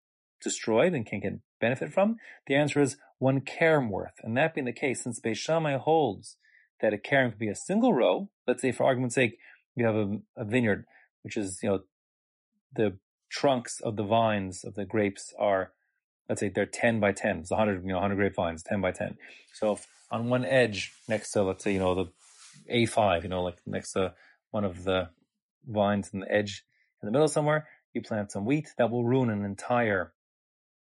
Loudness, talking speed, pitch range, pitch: -29 LUFS, 205 wpm, 100-130 Hz, 115 Hz